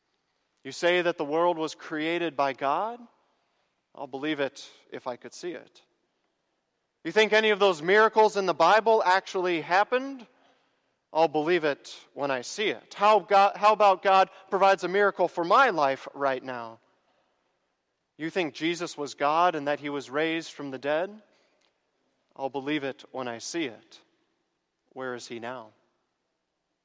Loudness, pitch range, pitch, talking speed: -25 LUFS, 140-195 Hz, 165 Hz, 160 wpm